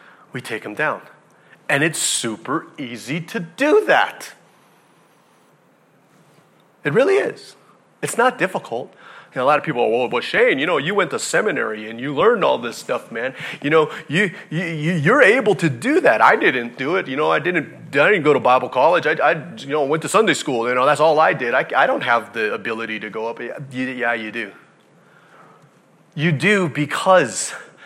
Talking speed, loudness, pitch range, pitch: 205 wpm, -18 LUFS, 120-185 Hz, 155 Hz